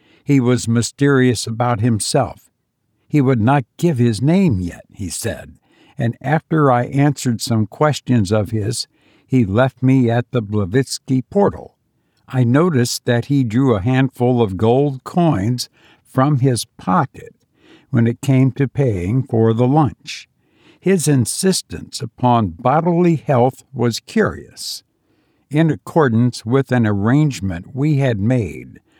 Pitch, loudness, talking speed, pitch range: 125 Hz, -17 LUFS, 135 wpm, 115-140 Hz